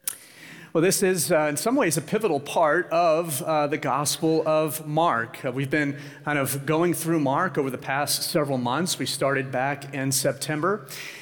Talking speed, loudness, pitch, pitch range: 180 wpm, -24 LUFS, 150 Hz, 140-165 Hz